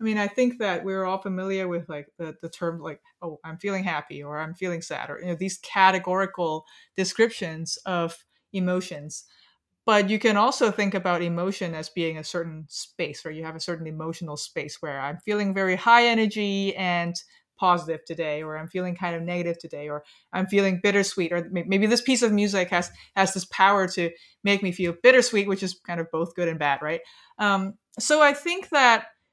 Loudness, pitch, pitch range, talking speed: -24 LUFS, 185 Hz, 165-200 Hz, 200 wpm